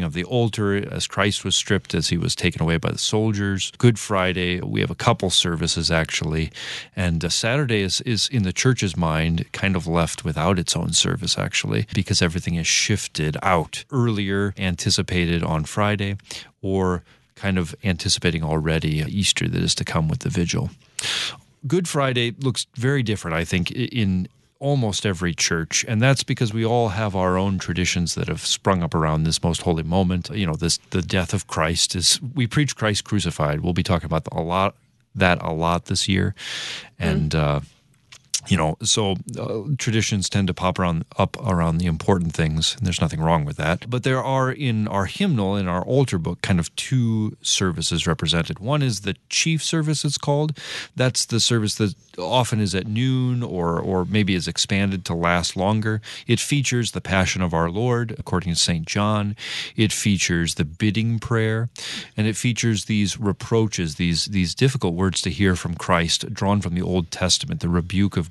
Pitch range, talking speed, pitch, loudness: 85-115 Hz, 185 wpm, 100 Hz, -22 LUFS